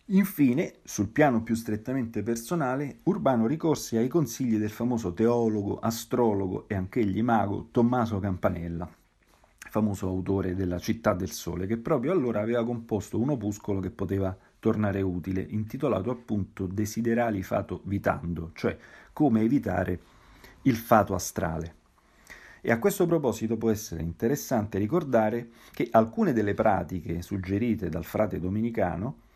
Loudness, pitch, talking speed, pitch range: -28 LUFS, 110 Hz, 130 wpm, 95-115 Hz